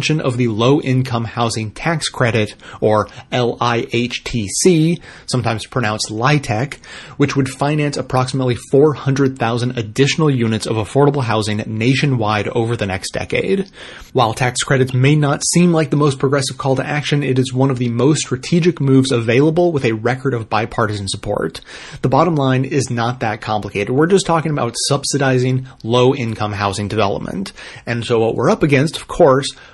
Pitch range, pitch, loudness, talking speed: 115-140 Hz, 130 Hz, -16 LUFS, 160 wpm